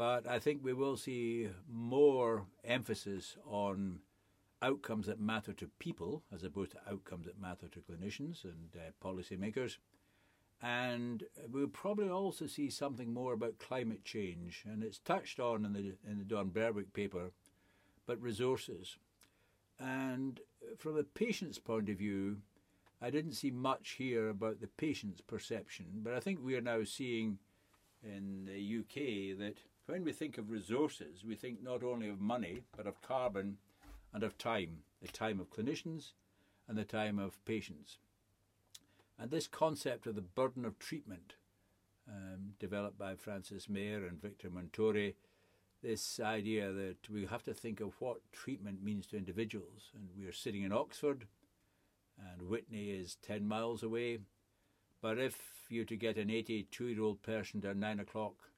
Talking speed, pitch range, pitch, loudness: 155 wpm, 100-120 Hz, 105 Hz, -41 LUFS